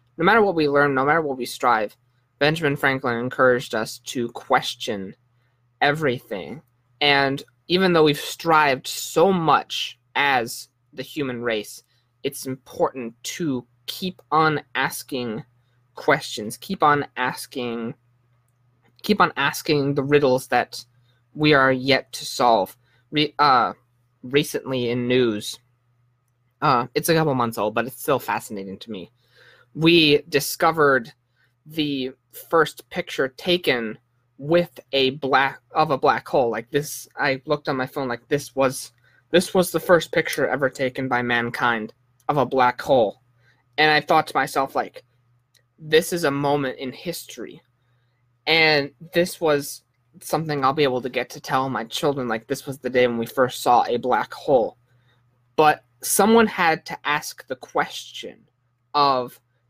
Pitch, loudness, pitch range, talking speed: 130 Hz, -21 LUFS, 125-150 Hz, 150 wpm